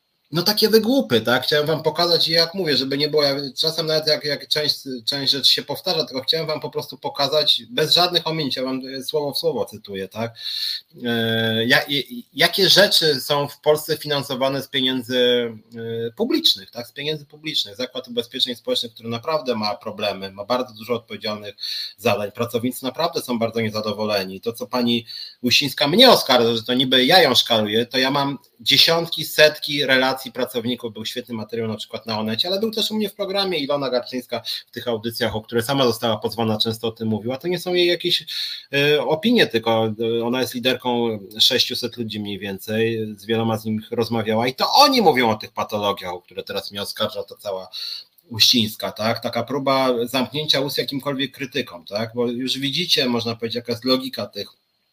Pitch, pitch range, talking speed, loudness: 130 Hz, 115-150 Hz, 185 wpm, -20 LUFS